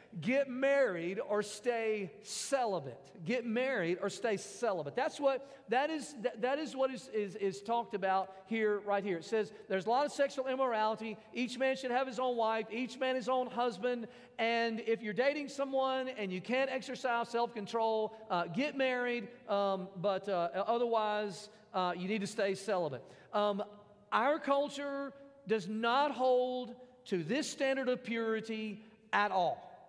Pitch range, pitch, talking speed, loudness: 210-260 Hz, 230 Hz, 165 wpm, -35 LUFS